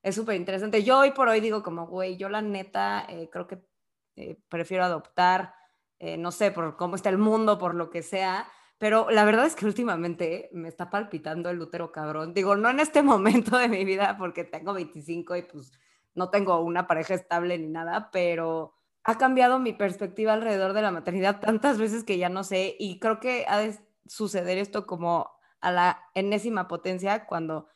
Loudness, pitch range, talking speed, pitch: -26 LUFS, 170-215 Hz, 195 wpm, 190 Hz